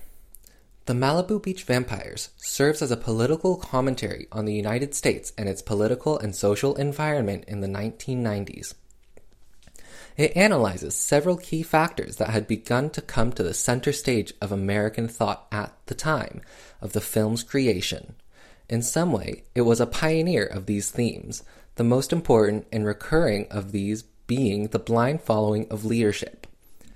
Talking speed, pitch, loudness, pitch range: 155 wpm, 115 Hz, -25 LUFS, 105-145 Hz